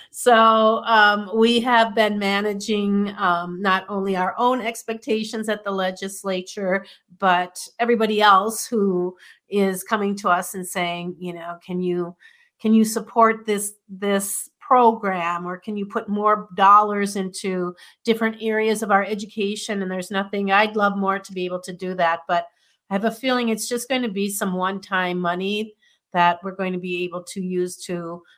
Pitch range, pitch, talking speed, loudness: 185-220 Hz, 200 Hz, 170 wpm, -21 LUFS